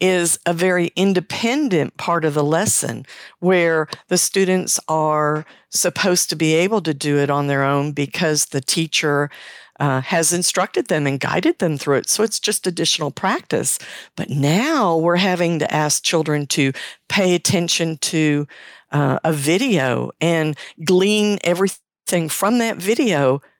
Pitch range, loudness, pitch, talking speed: 150-185 Hz, -18 LUFS, 165 Hz, 150 wpm